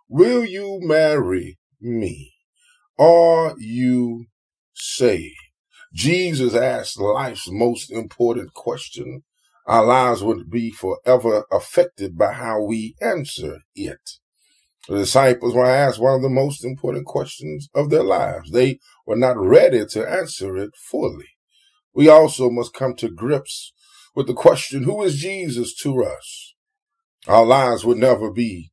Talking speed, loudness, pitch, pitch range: 135 wpm, -18 LUFS, 130 Hz, 115-165 Hz